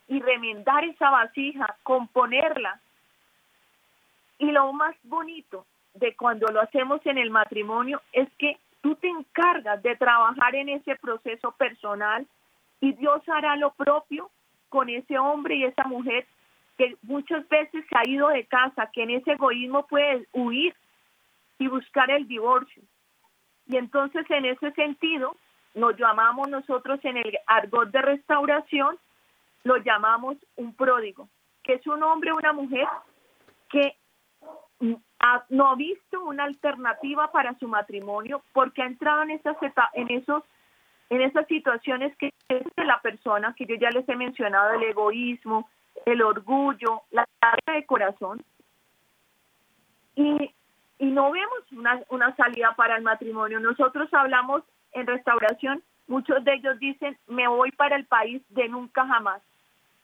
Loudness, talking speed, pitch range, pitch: -24 LUFS, 145 wpm, 235-285 Hz, 260 Hz